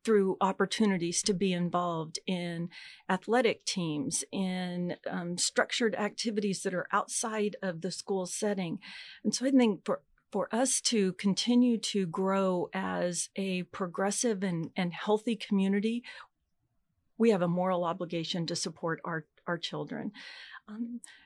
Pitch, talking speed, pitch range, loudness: 195 Hz, 135 wpm, 175-220 Hz, -31 LUFS